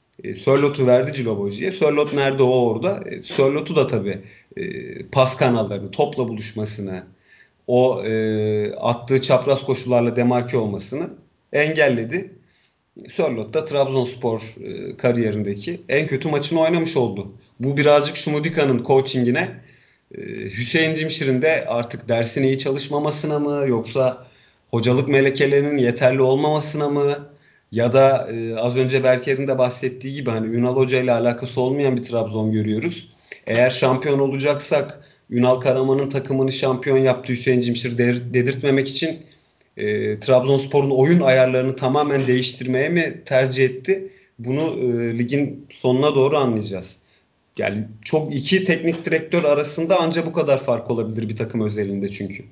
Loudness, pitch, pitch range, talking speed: -19 LUFS, 130 Hz, 120-145 Hz, 125 wpm